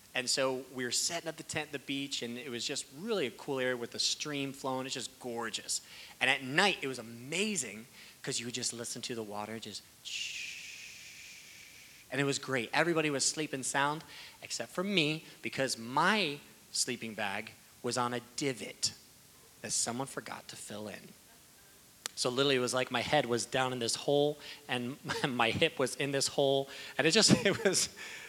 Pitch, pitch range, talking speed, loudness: 135 Hz, 120-150 Hz, 190 wpm, -33 LUFS